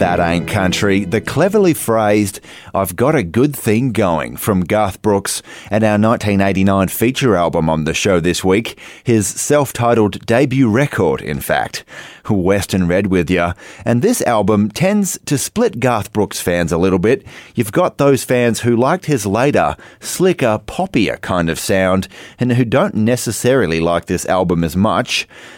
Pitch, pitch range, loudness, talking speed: 105 Hz, 95-125 Hz, -15 LUFS, 165 wpm